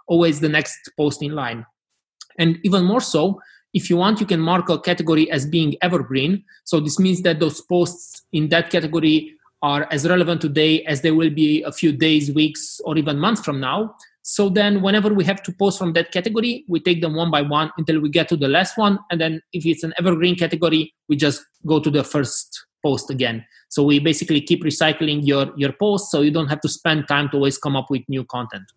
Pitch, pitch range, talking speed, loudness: 160 Hz, 150-180 Hz, 225 wpm, -19 LUFS